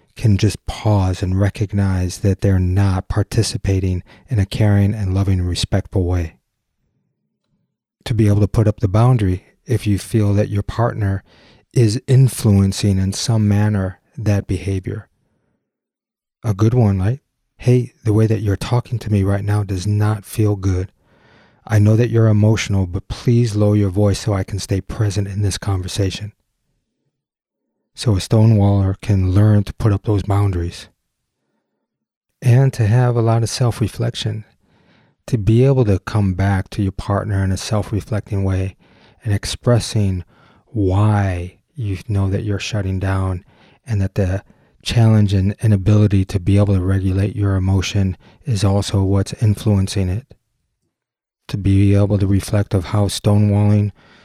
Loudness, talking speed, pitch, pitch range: -18 LUFS, 155 wpm, 105 Hz, 95-110 Hz